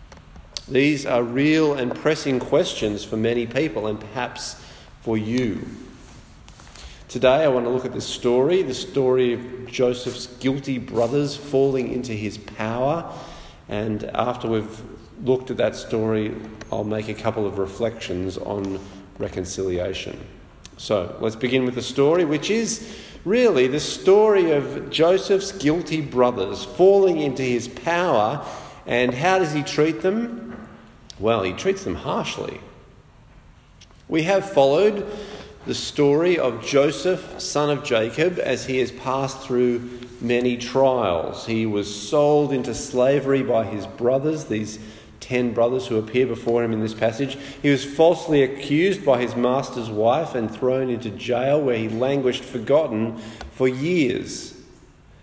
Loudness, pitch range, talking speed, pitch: -22 LUFS, 110-145 Hz, 140 wpm, 125 Hz